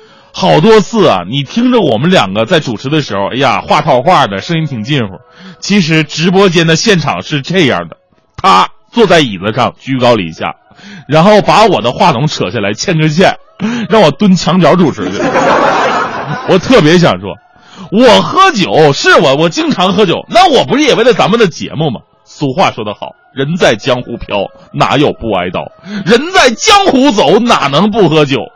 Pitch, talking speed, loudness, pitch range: 180 Hz, 260 characters per minute, -9 LUFS, 145-215 Hz